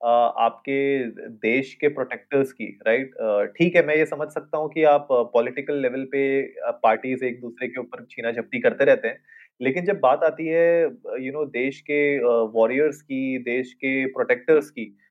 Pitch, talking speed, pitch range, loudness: 140 Hz, 205 wpm, 125-155 Hz, -23 LUFS